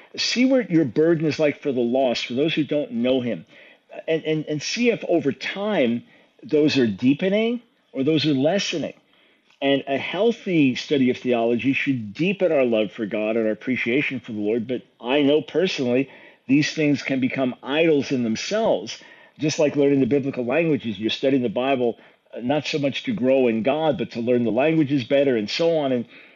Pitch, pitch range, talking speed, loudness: 140 Hz, 125-155 Hz, 195 wpm, -22 LUFS